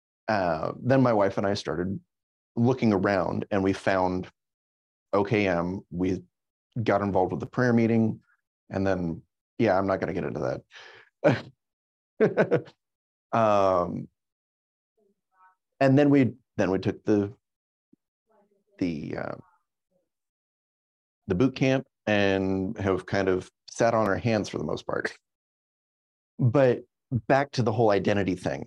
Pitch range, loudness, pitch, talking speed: 90-125 Hz, -26 LUFS, 100 Hz, 130 wpm